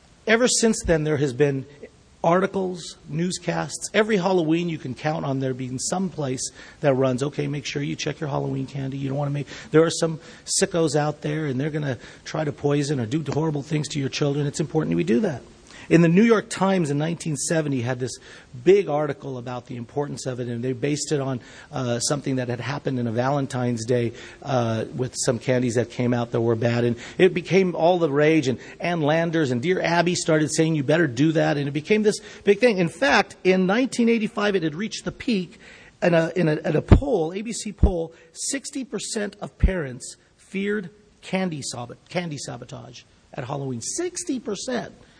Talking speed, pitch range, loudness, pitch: 200 wpm, 135-180 Hz, -23 LUFS, 155 Hz